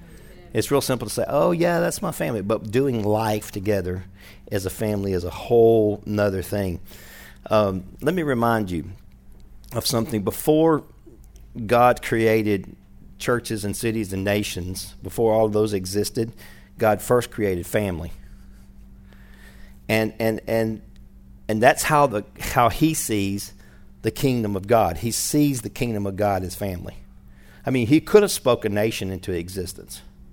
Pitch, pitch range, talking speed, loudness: 105 Hz, 95-115 Hz, 155 wpm, -22 LUFS